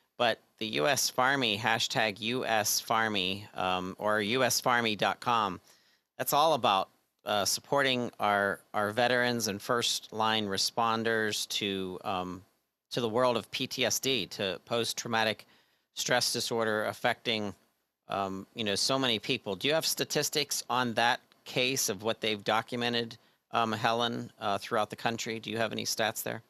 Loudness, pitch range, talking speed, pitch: -30 LUFS, 105-120 Hz, 145 wpm, 115 Hz